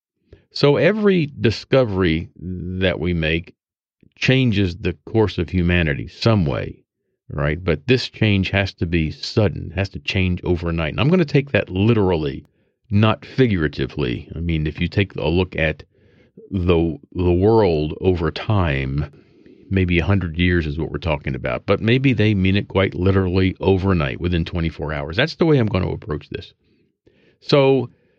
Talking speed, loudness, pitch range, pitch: 160 wpm, -19 LUFS, 80-105 Hz, 90 Hz